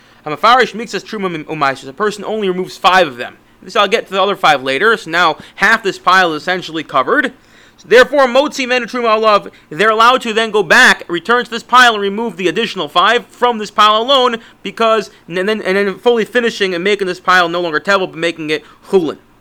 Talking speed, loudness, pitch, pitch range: 210 wpm, -13 LUFS, 200 Hz, 180-230 Hz